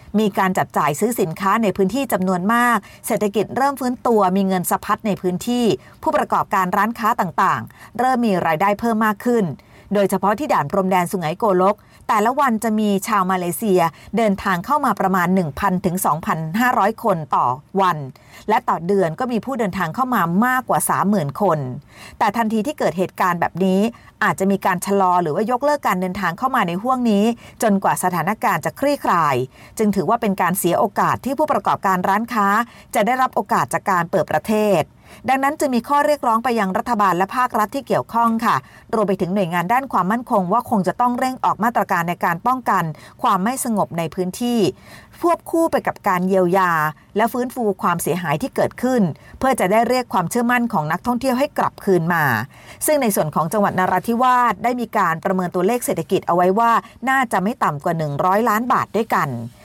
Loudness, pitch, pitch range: -19 LUFS, 200 Hz, 185-235 Hz